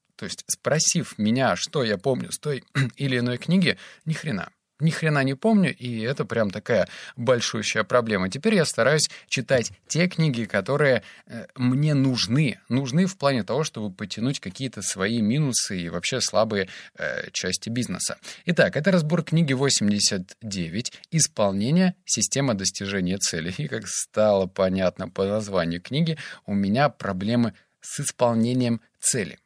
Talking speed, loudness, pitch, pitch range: 145 wpm, -24 LUFS, 120 Hz, 105-150 Hz